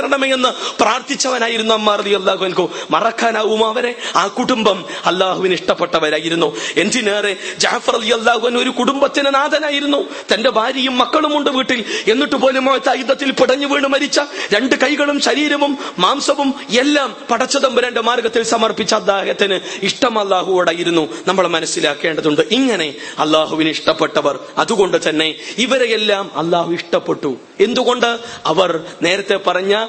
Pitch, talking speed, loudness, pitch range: 230 Hz, 85 wpm, -15 LUFS, 185-265 Hz